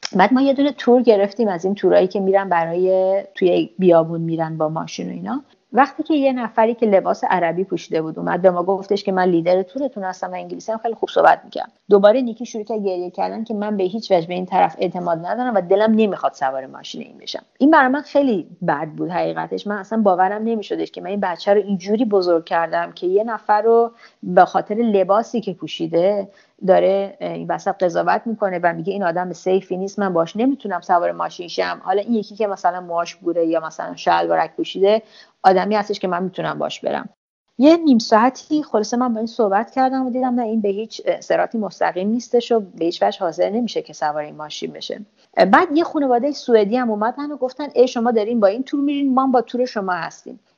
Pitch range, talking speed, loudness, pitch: 180-235 Hz, 210 wpm, -19 LUFS, 205 Hz